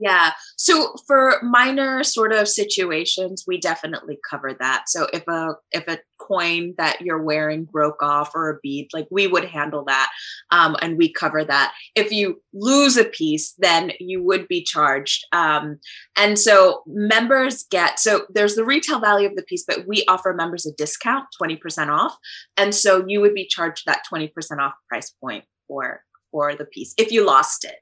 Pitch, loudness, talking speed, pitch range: 185 Hz, -19 LUFS, 185 wpm, 155-215 Hz